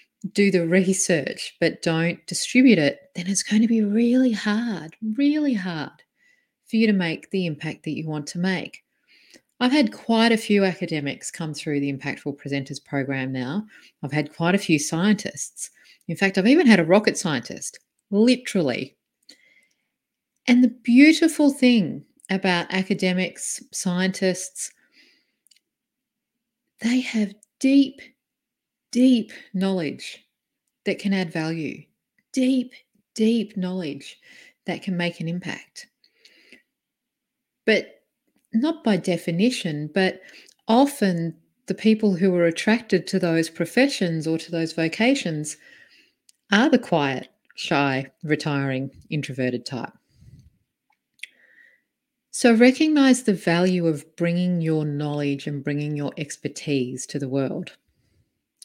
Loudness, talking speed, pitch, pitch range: -22 LUFS, 120 wpm, 190 Hz, 160-240 Hz